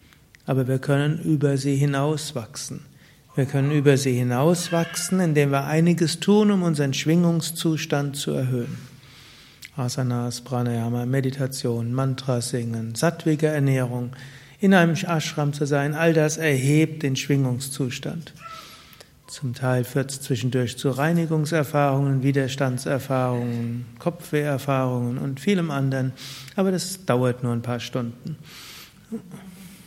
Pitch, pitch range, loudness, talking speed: 140 Hz, 130-160 Hz, -23 LUFS, 115 wpm